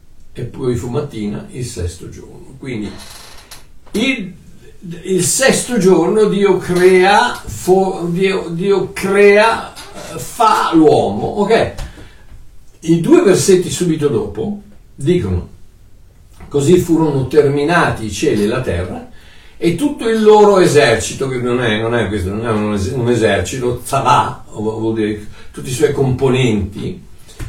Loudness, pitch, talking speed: -14 LUFS, 135 Hz, 125 wpm